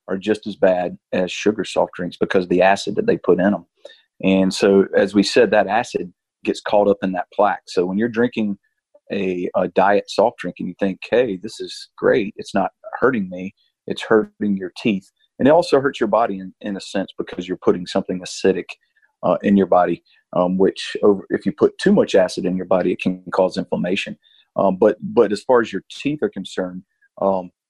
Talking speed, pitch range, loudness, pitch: 215 wpm, 90-105 Hz, -19 LUFS, 95 Hz